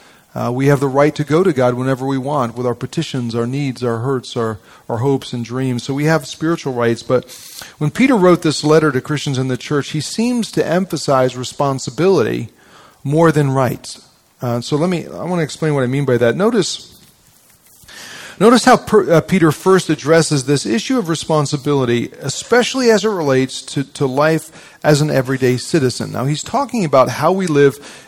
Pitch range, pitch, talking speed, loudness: 130-160 Hz, 145 Hz, 195 wpm, -16 LUFS